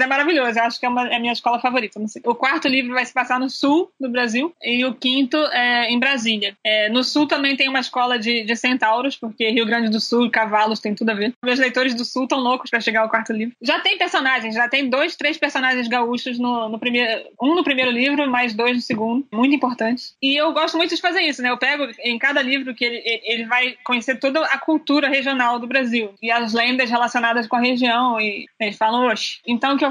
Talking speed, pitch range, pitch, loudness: 245 wpm, 235-270 Hz, 250 Hz, -19 LUFS